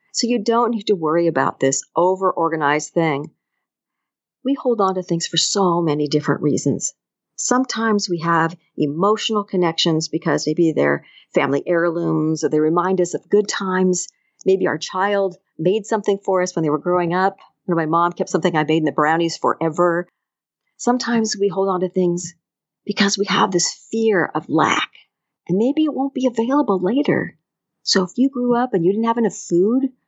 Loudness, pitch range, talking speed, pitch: -19 LUFS, 165-210 Hz, 185 wpm, 185 Hz